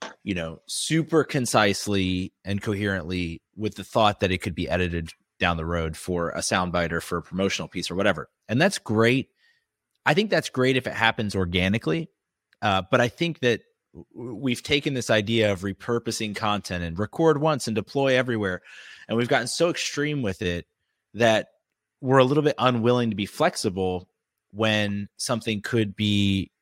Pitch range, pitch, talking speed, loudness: 95-125 Hz, 105 Hz, 175 wpm, -24 LUFS